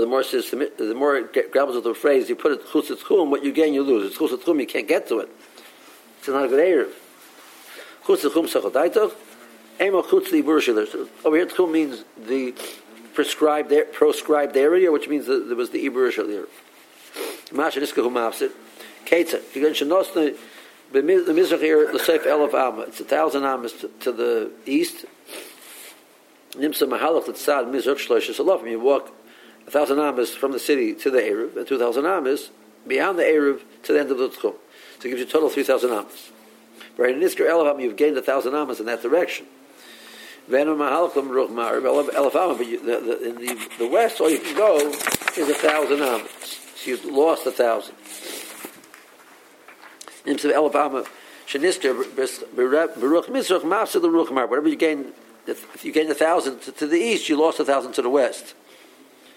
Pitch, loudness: 370 Hz, -21 LUFS